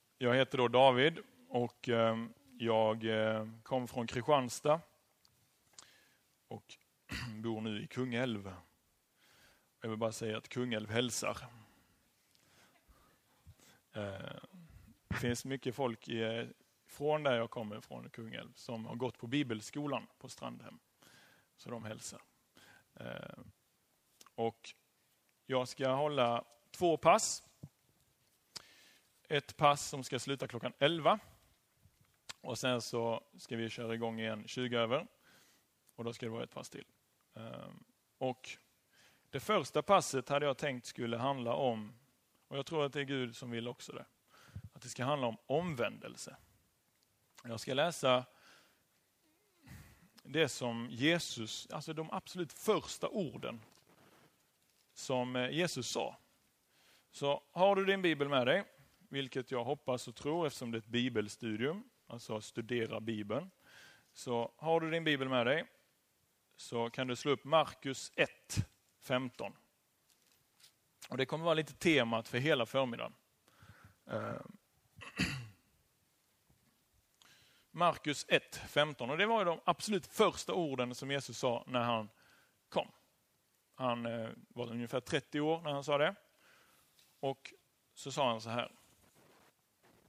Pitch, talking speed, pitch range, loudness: 125 Hz, 125 wpm, 115-145 Hz, -36 LUFS